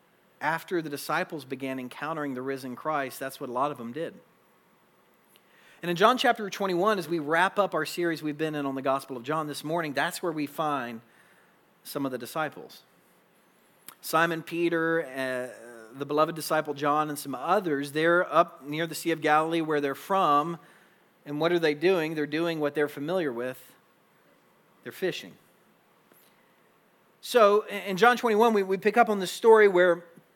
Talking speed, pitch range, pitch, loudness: 175 wpm, 145-175 Hz, 155 Hz, -27 LUFS